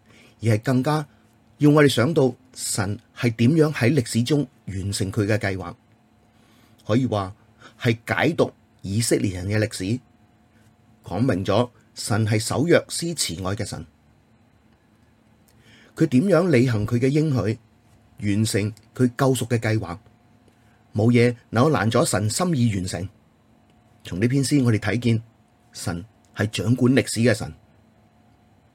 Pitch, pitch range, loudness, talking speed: 115 Hz, 110-120 Hz, -22 LUFS, 190 characters per minute